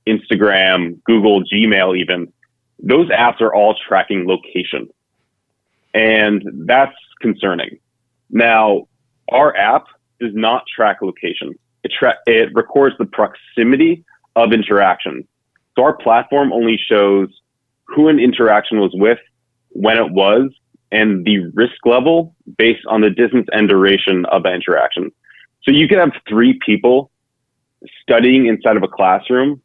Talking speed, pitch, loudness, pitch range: 130 wpm, 115 Hz, -14 LUFS, 105-125 Hz